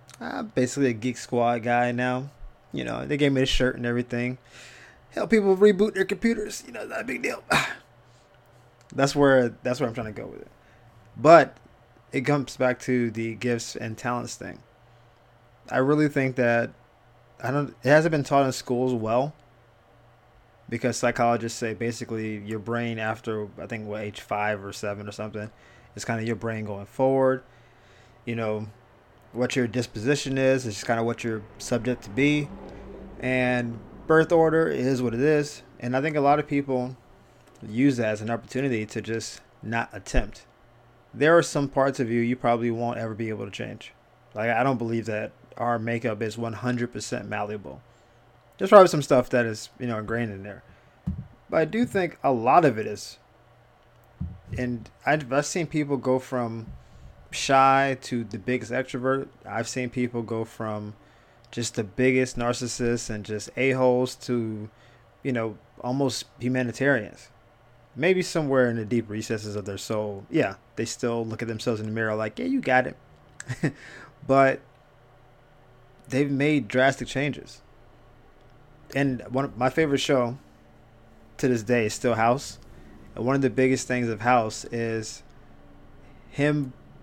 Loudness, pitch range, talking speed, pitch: -25 LUFS, 115-130 Hz, 170 wpm, 120 Hz